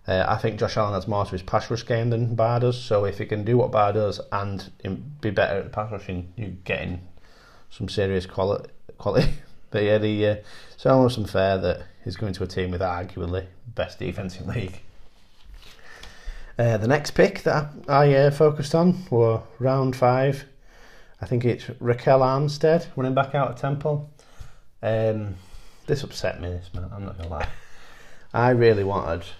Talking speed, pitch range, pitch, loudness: 185 wpm, 95-125 Hz, 110 Hz, -24 LUFS